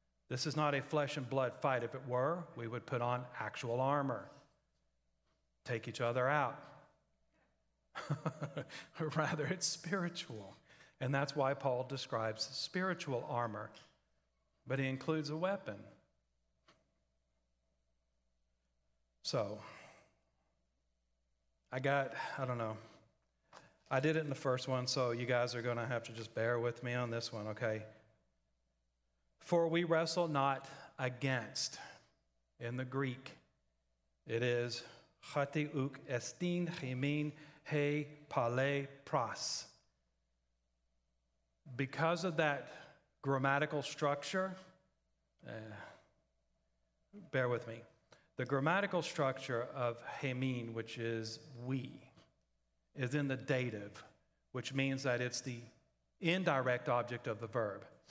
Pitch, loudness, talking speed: 125 Hz, -38 LUFS, 110 wpm